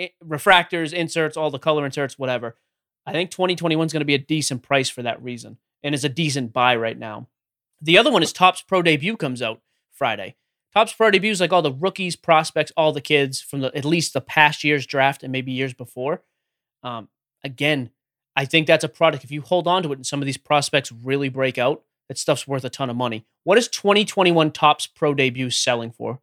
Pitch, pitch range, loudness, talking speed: 145 Hz, 130-160 Hz, -20 LUFS, 220 wpm